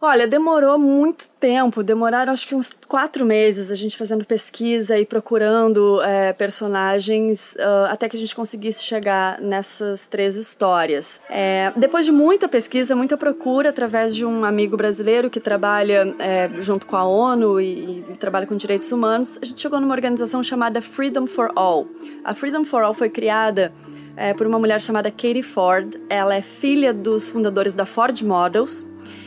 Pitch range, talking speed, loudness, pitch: 200-255 Hz, 170 wpm, -19 LUFS, 220 Hz